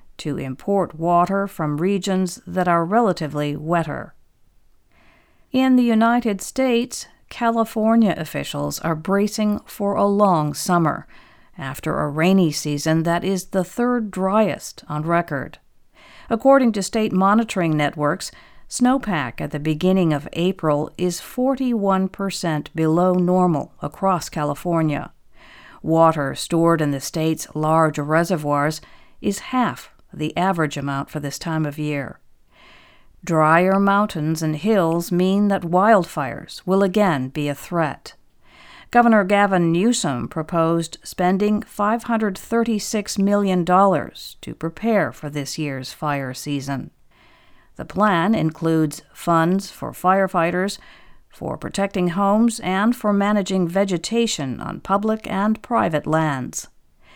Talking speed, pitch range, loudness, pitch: 115 wpm, 155-205 Hz, -20 LUFS, 180 Hz